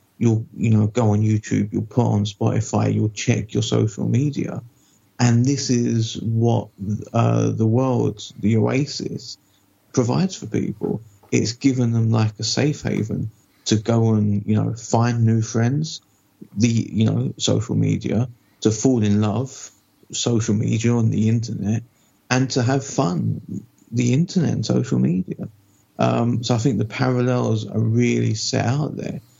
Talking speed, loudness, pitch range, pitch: 155 wpm, -21 LUFS, 105-125 Hz, 115 Hz